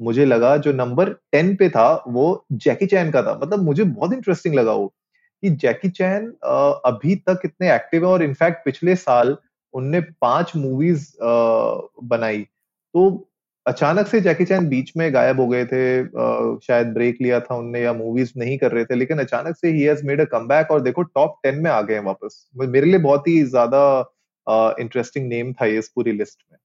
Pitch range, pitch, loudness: 125-180 Hz, 140 Hz, -19 LUFS